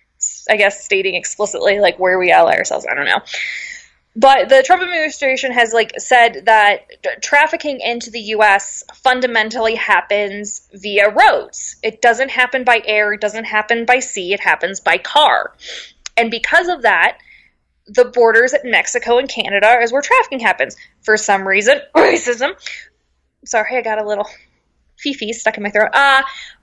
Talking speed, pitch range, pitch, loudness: 165 wpm, 210-275 Hz, 235 Hz, -14 LUFS